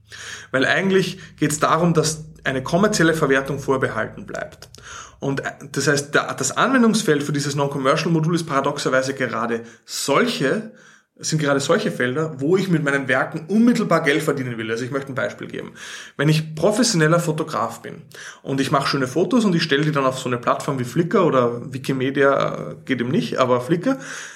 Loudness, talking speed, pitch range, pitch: -20 LUFS, 175 wpm, 135-165 Hz, 145 Hz